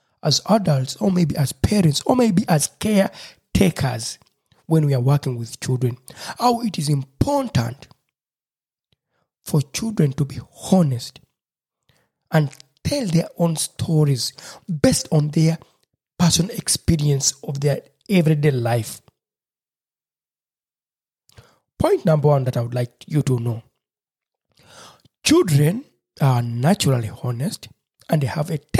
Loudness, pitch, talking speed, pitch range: -20 LUFS, 150 Hz, 120 wpm, 130-170 Hz